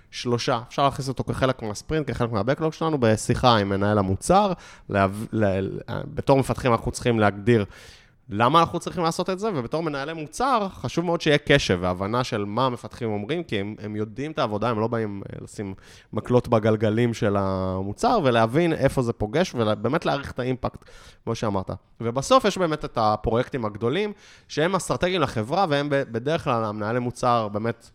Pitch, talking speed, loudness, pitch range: 120 Hz, 165 wpm, -24 LUFS, 105-145 Hz